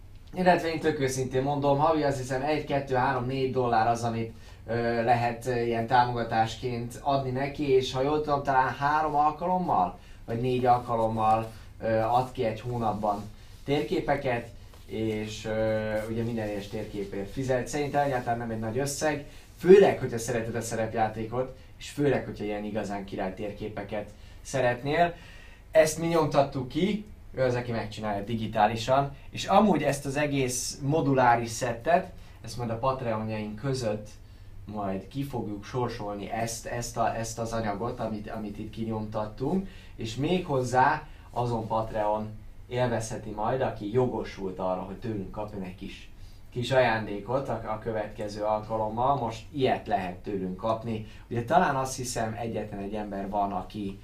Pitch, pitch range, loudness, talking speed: 115 Hz, 105-130 Hz, -28 LUFS, 150 wpm